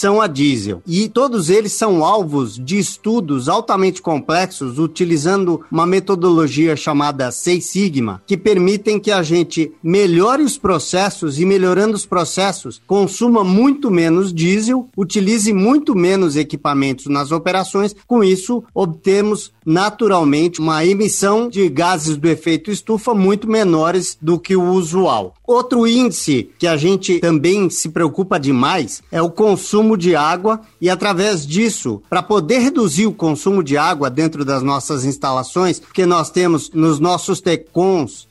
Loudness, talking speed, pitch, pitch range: -15 LUFS, 145 wpm, 185 Hz, 160-205 Hz